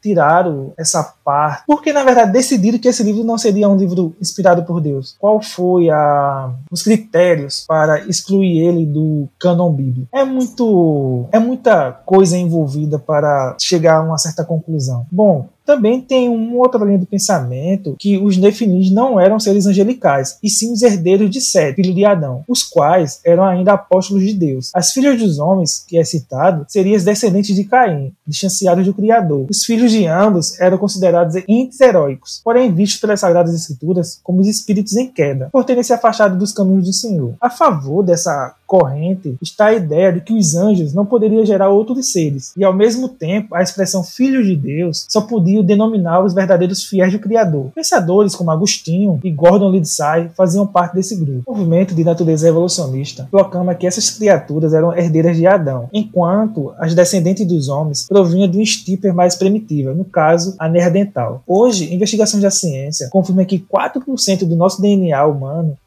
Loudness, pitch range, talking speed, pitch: -14 LUFS, 165-210 Hz, 175 wpm, 185 Hz